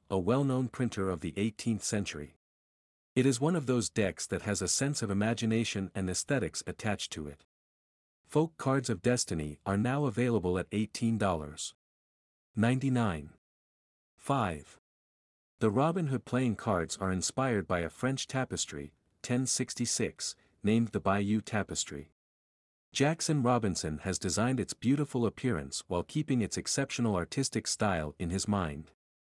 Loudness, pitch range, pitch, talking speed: -32 LUFS, 85-125 Hz, 105 Hz, 135 wpm